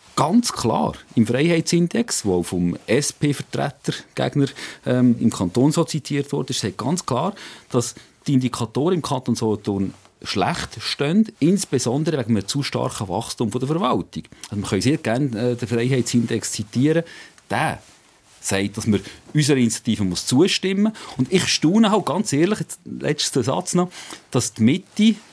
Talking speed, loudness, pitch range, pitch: 150 wpm, -21 LUFS, 115-165 Hz, 135 Hz